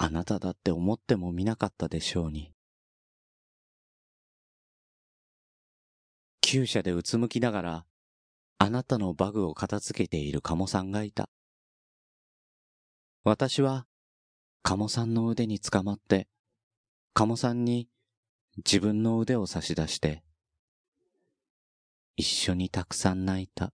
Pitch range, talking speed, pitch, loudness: 85-115 Hz, 225 characters per minute, 100 Hz, -29 LUFS